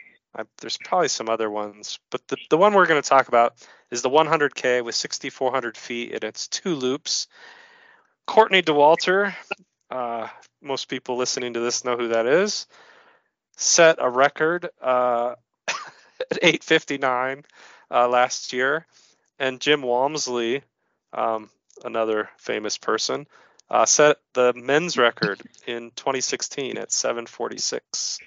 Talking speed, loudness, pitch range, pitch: 130 wpm, -22 LUFS, 120-165 Hz, 130 Hz